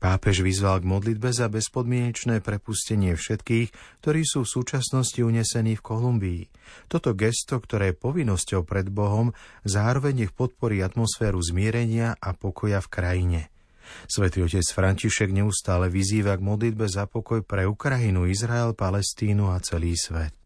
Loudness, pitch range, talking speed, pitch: -25 LUFS, 95-115 Hz, 140 wpm, 105 Hz